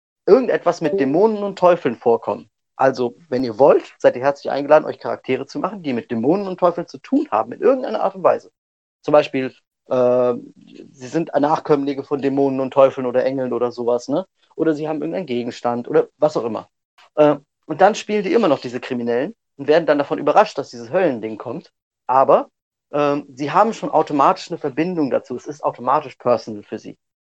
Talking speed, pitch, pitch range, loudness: 195 wpm, 145 Hz, 125-160 Hz, -19 LUFS